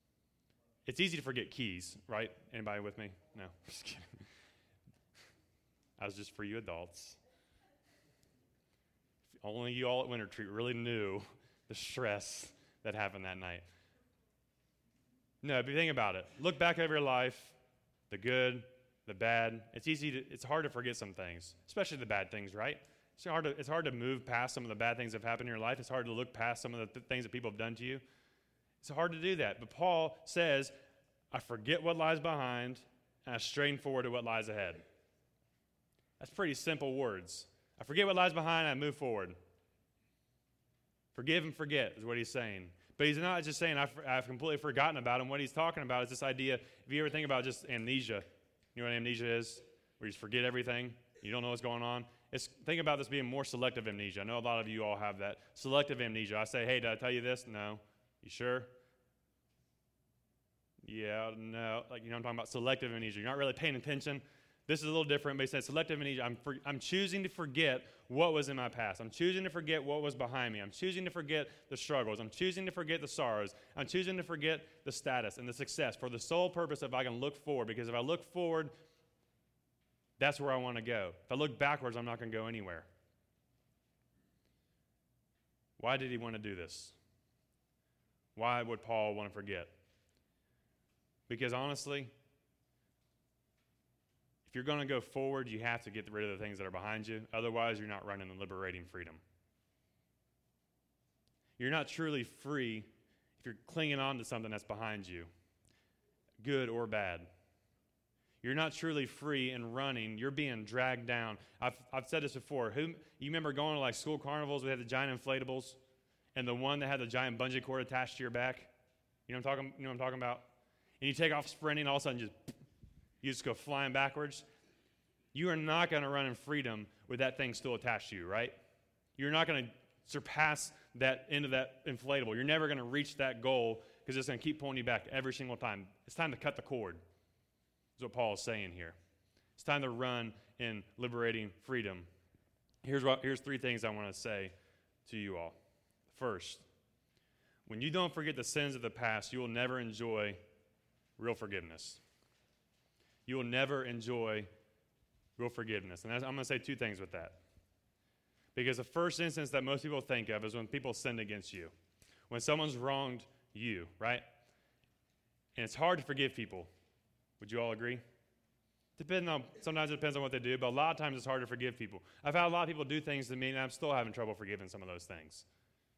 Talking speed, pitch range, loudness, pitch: 205 wpm, 110-140 Hz, -38 LUFS, 125 Hz